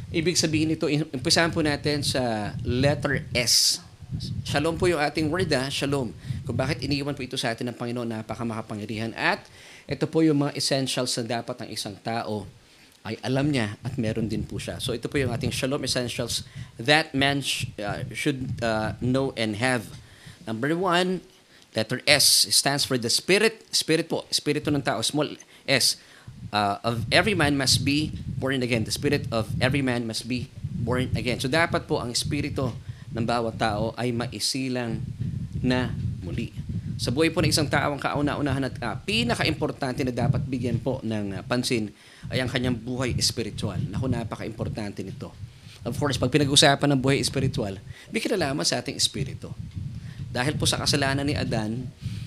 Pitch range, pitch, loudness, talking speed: 115-145 Hz, 130 Hz, -25 LUFS, 170 wpm